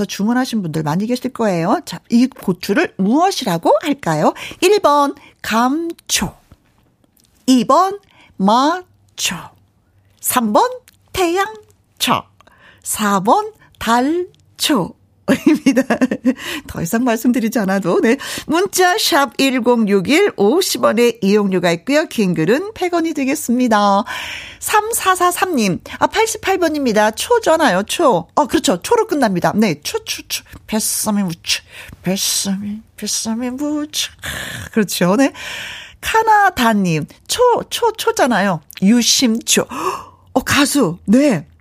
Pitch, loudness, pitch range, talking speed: 255 Hz, -16 LUFS, 210-330 Hz, 195 characters per minute